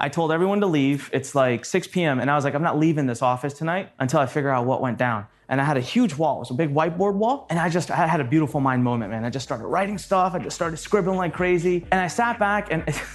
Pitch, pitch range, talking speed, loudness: 160 Hz, 135-180 Hz, 290 wpm, -23 LUFS